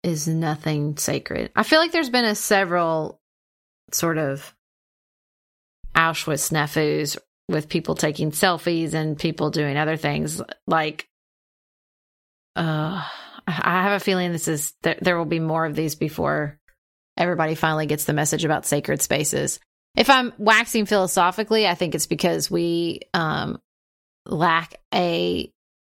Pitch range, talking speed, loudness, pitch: 150-180 Hz, 135 wpm, -22 LUFS, 160 Hz